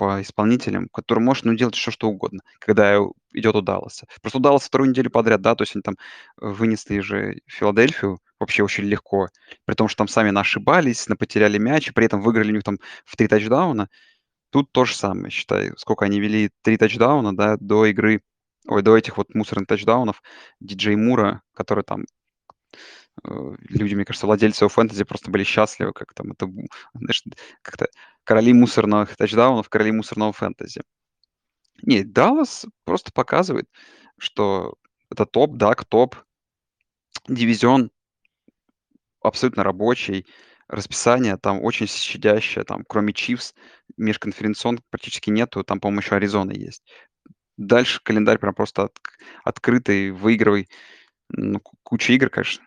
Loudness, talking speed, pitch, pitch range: -20 LUFS, 140 wpm, 110 Hz, 105-115 Hz